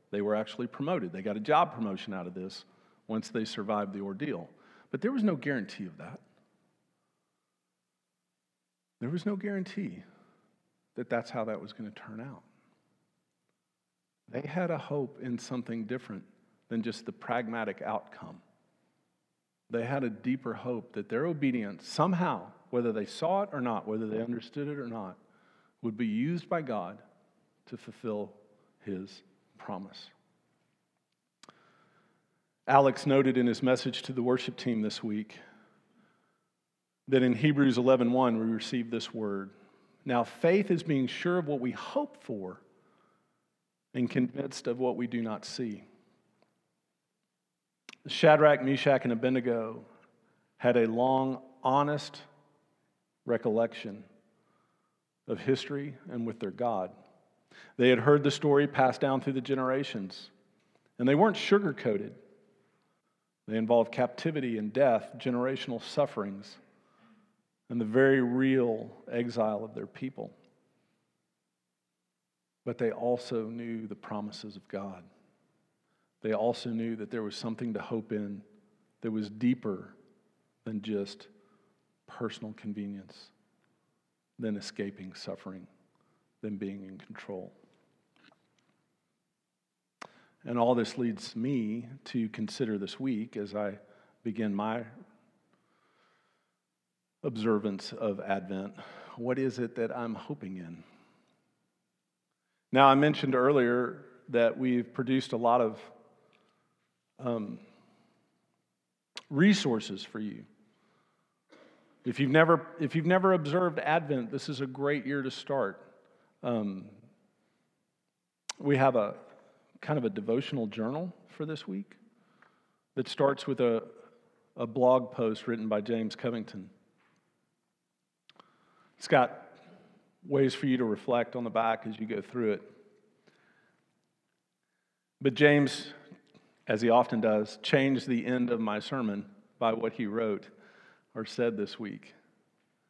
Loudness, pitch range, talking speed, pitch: -31 LUFS, 110-140 Hz, 125 wpm, 125 Hz